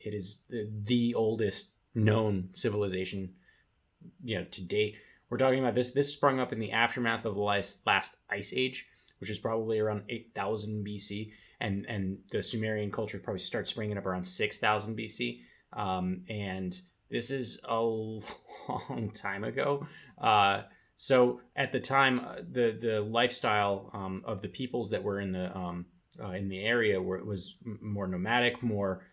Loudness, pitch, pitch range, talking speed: -32 LUFS, 105 Hz, 100-115 Hz, 165 wpm